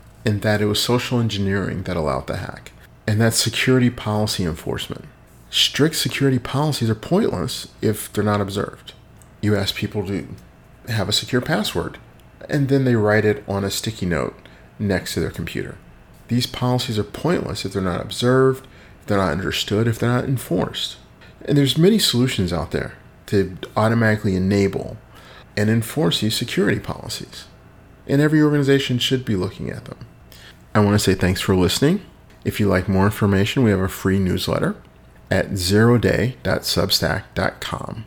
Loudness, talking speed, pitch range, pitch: -20 LUFS, 160 wpm, 95-125 Hz, 105 Hz